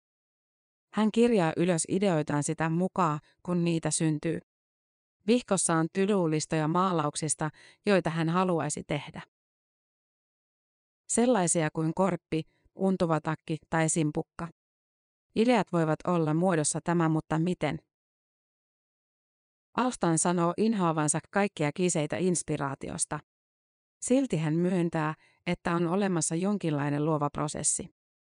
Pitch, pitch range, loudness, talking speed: 165 Hz, 155-185 Hz, -28 LUFS, 95 wpm